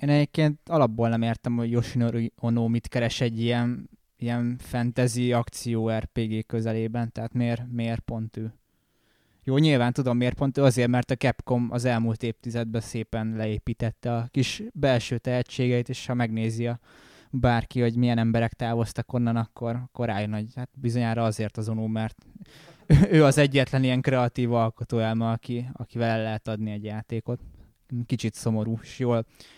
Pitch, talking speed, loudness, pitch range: 120 Hz, 155 wpm, -26 LUFS, 115-125 Hz